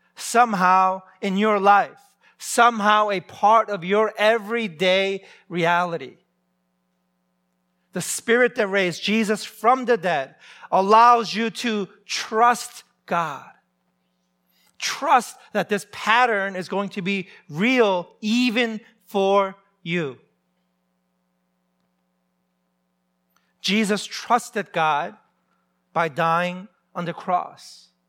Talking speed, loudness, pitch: 95 wpm, -21 LUFS, 190 Hz